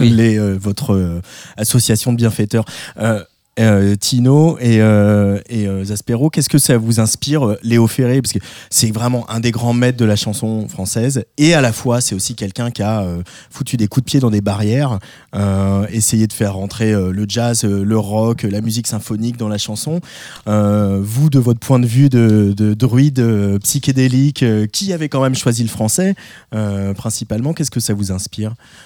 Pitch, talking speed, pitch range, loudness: 115 Hz, 200 wpm, 105-125 Hz, -15 LUFS